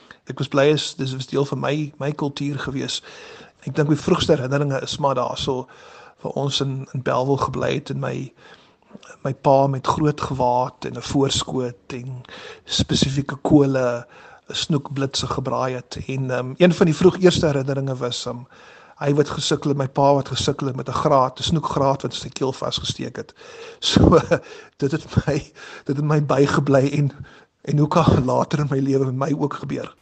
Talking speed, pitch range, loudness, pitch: 185 wpm, 130-150 Hz, -21 LUFS, 140 Hz